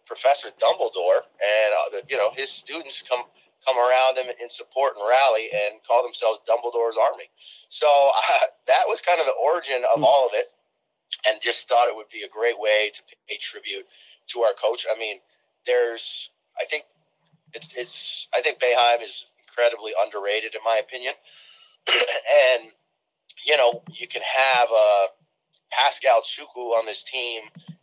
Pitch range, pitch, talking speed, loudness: 115-170 Hz, 125 Hz, 170 wpm, -22 LUFS